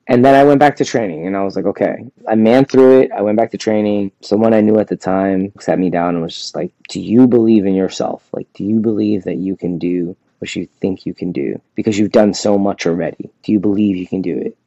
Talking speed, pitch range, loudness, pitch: 270 wpm, 95-110 Hz, -15 LUFS, 105 Hz